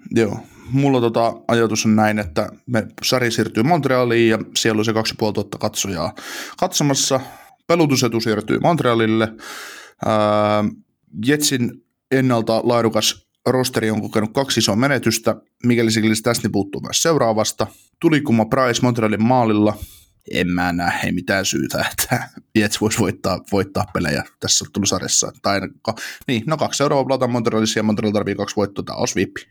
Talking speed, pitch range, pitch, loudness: 140 wpm, 110-125 Hz, 115 Hz, -19 LUFS